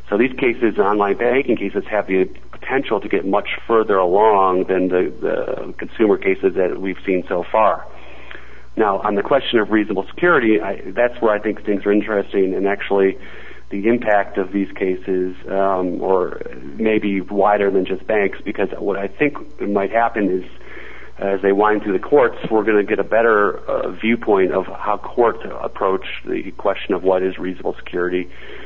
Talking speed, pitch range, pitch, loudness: 180 wpm, 95-110 Hz, 100 Hz, -18 LUFS